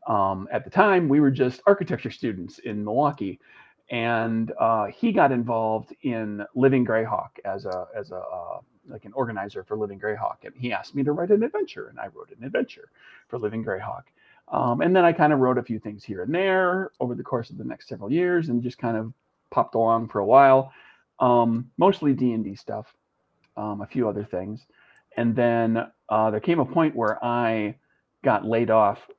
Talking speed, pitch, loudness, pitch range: 200 wpm, 120 Hz, -24 LUFS, 110-150 Hz